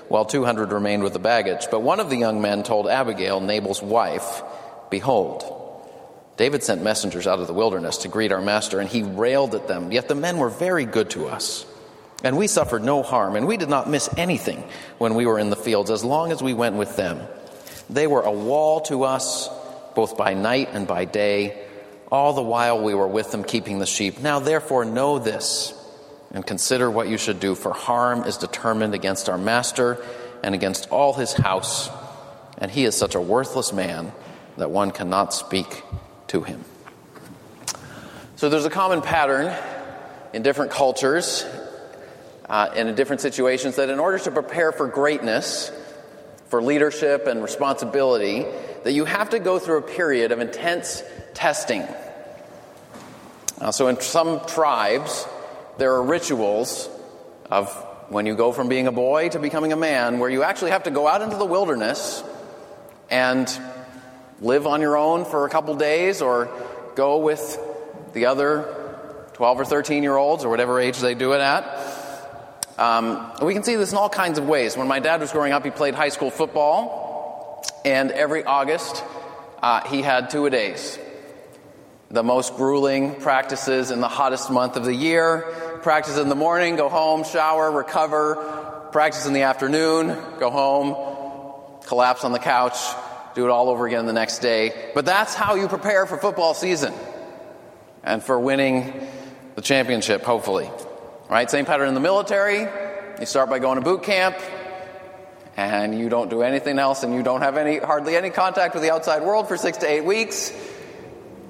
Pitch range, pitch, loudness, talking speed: 120-155 Hz, 135 Hz, -22 LUFS, 180 wpm